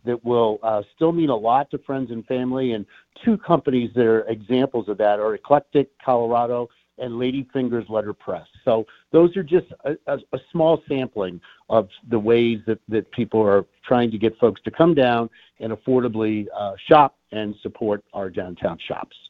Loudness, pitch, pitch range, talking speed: -21 LUFS, 120 Hz, 110-135 Hz, 175 wpm